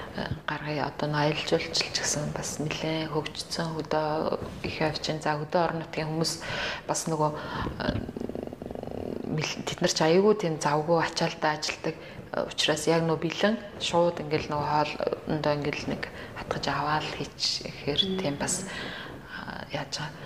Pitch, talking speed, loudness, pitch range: 155 Hz, 120 wpm, -29 LUFS, 150-165 Hz